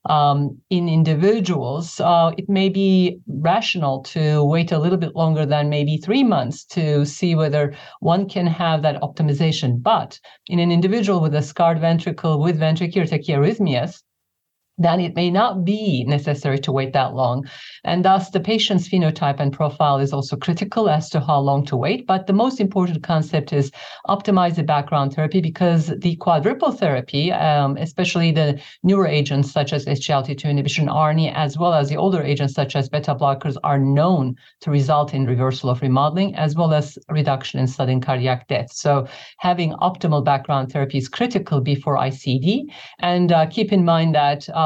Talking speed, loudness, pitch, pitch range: 175 wpm, -19 LUFS, 155 Hz, 145-180 Hz